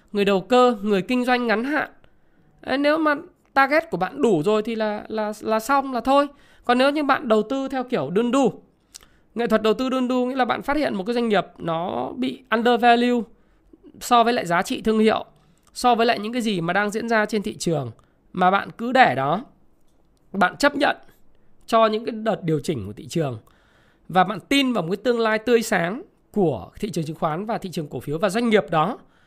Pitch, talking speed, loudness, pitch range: 220 Hz, 230 wpm, -21 LUFS, 185-250 Hz